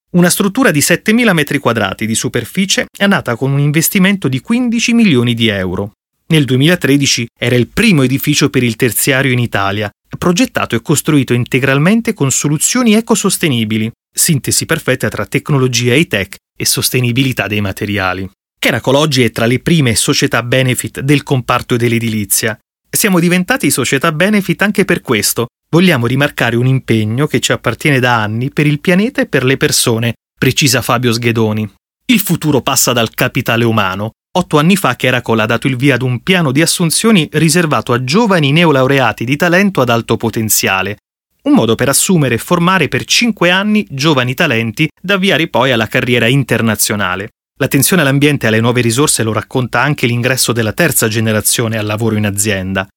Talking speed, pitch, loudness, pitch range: 165 wpm, 130 Hz, -12 LUFS, 115-165 Hz